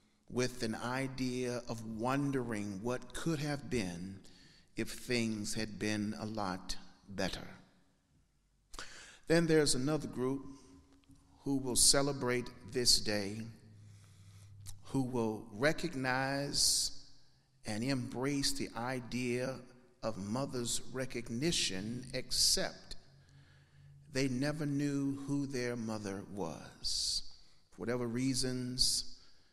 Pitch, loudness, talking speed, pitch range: 125 Hz, -35 LUFS, 95 wpm, 105-135 Hz